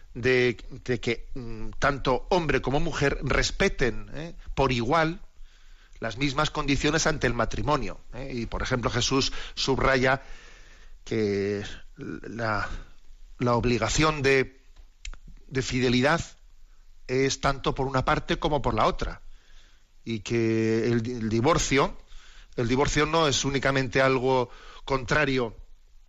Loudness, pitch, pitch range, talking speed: -26 LUFS, 130 Hz, 115-140 Hz, 120 wpm